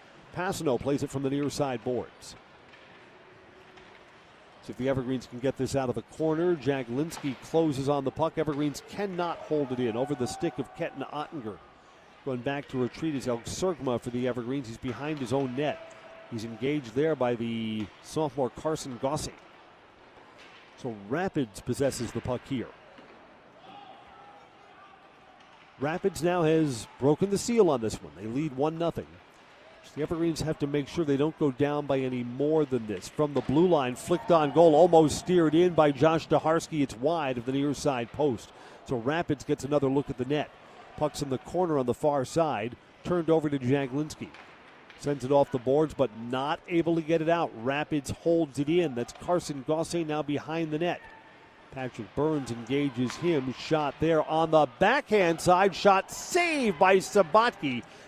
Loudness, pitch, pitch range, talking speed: -28 LUFS, 145 Hz, 130-160 Hz, 175 wpm